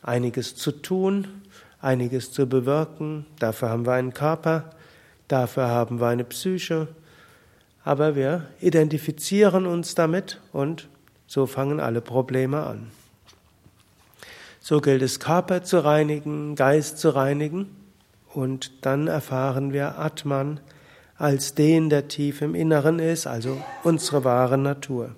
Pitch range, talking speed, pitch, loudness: 130-160 Hz, 125 wpm, 145 Hz, -24 LUFS